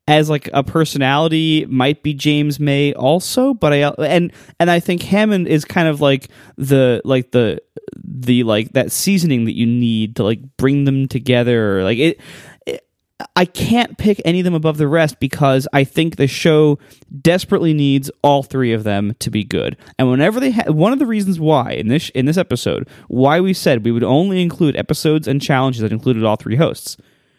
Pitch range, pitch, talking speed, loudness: 130-165 Hz, 145 Hz, 200 wpm, -16 LUFS